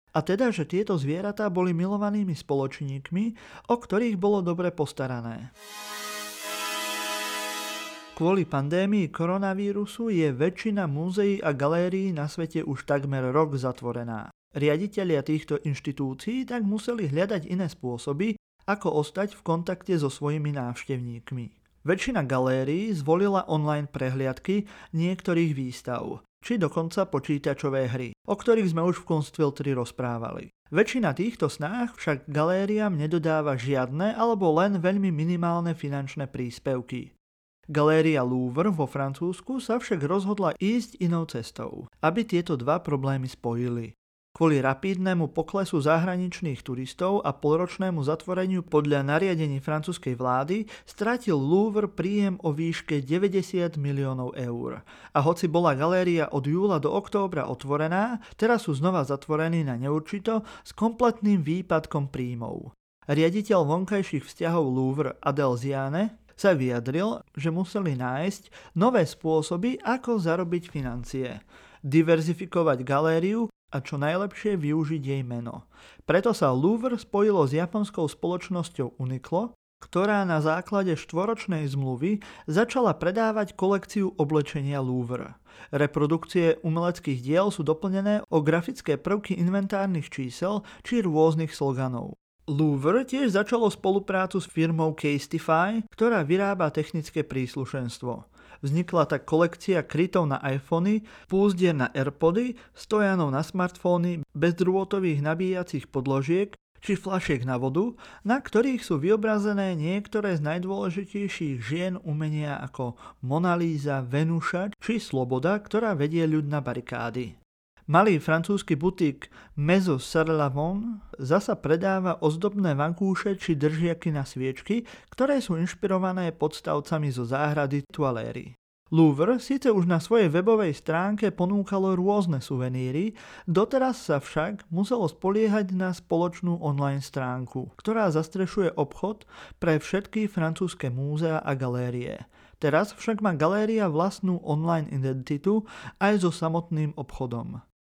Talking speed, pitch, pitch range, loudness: 120 wpm, 165 Hz, 145-195 Hz, -27 LUFS